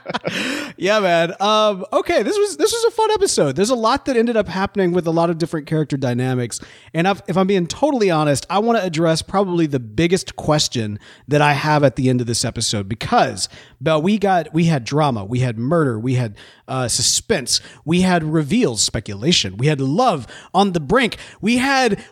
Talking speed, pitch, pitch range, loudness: 205 wpm, 165 Hz, 130-200 Hz, -18 LUFS